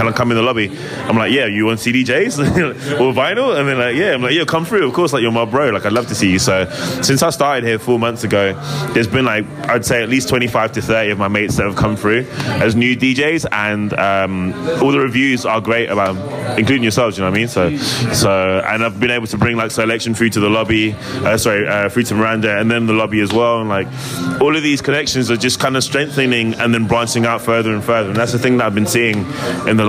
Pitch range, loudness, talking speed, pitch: 110-130 Hz, -15 LUFS, 265 wpm, 115 Hz